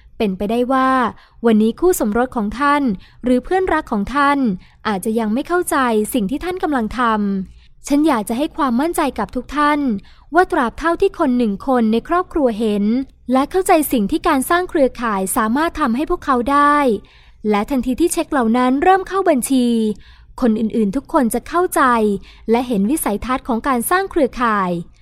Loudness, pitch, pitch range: -17 LUFS, 260 Hz, 230-305 Hz